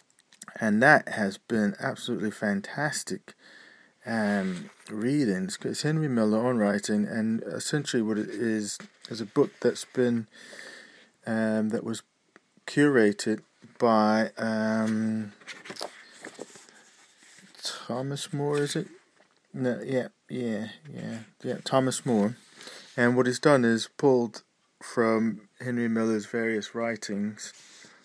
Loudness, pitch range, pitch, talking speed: -27 LUFS, 110-130 Hz, 115 Hz, 110 wpm